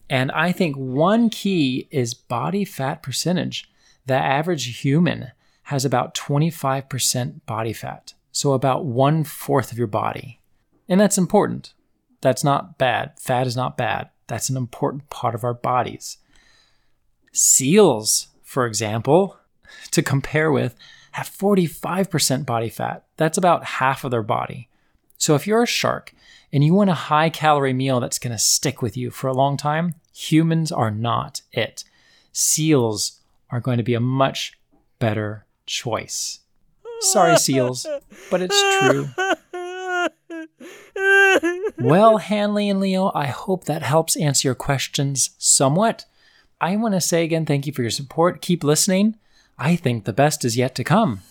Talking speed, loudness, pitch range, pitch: 150 wpm, -20 LUFS, 125-185 Hz, 145 Hz